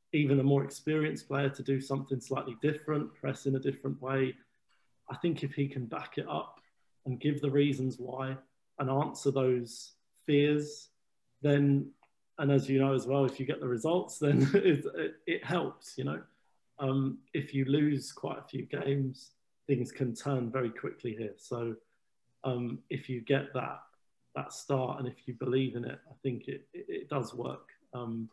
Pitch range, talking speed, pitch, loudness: 130-145 Hz, 180 wpm, 135 Hz, -33 LUFS